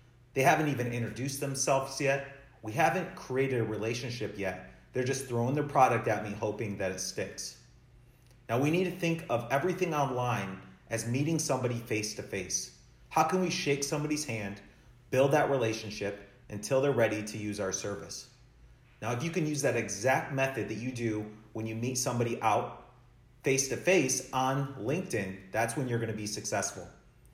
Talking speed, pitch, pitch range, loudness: 180 wpm, 125 Hz, 110-140 Hz, -31 LUFS